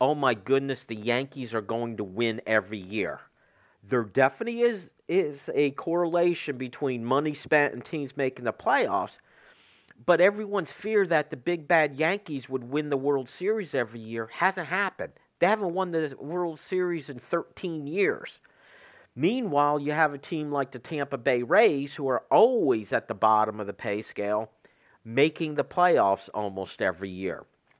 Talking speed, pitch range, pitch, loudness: 165 wpm, 120-170 Hz, 145 Hz, -27 LUFS